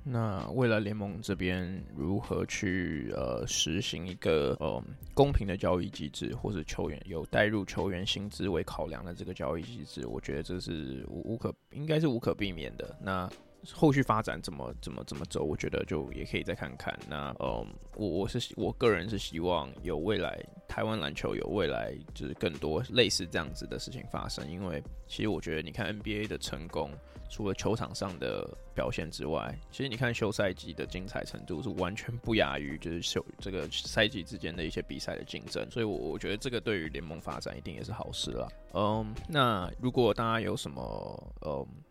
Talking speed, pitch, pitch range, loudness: 300 characters per minute, 95 Hz, 85-110 Hz, -34 LUFS